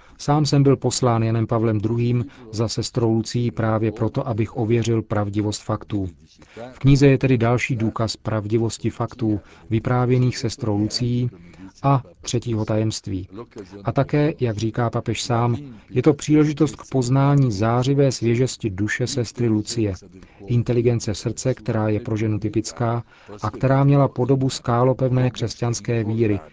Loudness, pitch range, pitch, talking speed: -21 LUFS, 110-125 Hz, 115 Hz, 135 wpm